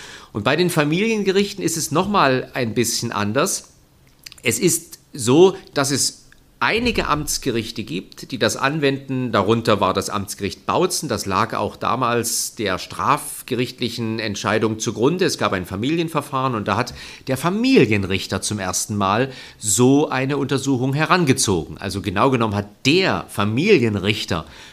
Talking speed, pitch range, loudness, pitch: 140 wpm, 105-140 Hz, -20 LUFS, 120 Hz